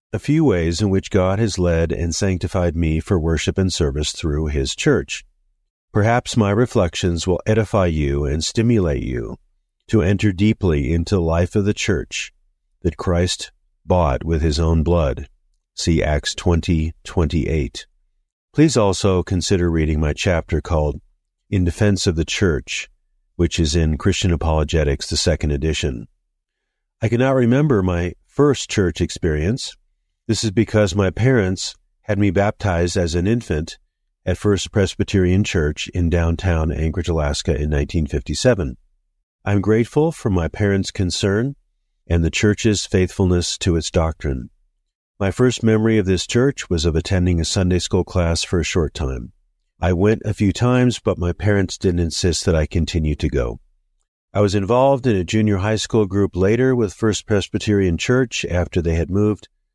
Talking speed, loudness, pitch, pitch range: 160 wpm, -19 LUFS, 90 Hz, 80-105 Hz